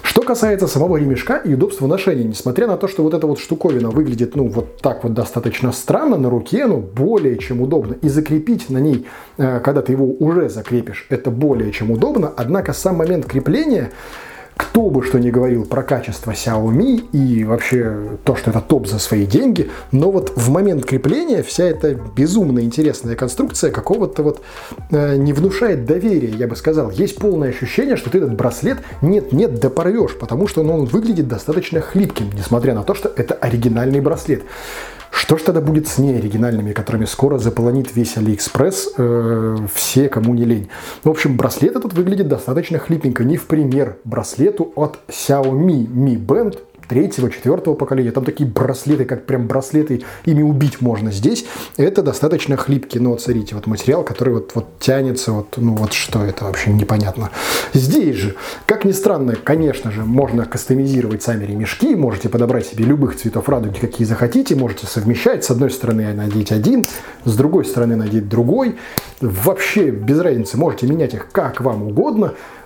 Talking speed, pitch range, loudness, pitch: 170 wpm, 115-150 Hz, -17 LUFS, 130 Hz